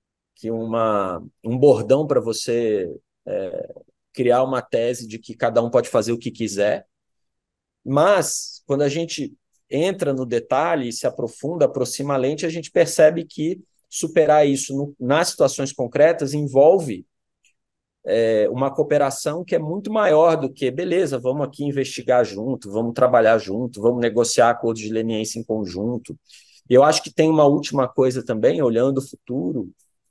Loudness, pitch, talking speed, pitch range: -20 LUFS, 130 Hz, 155 wpm, 115-145 Hz